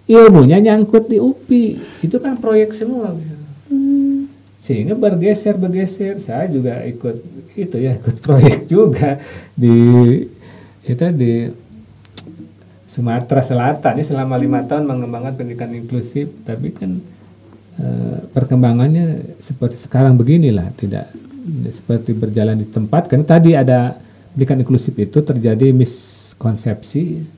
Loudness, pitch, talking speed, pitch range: -14 LUFS, 135 Hz, 110 wpm, 115-165 Hz